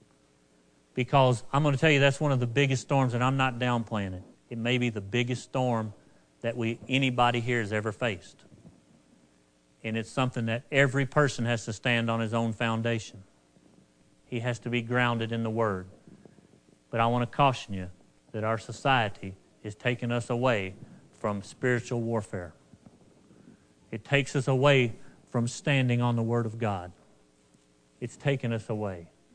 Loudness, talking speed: -28 LUFS, 170 wpm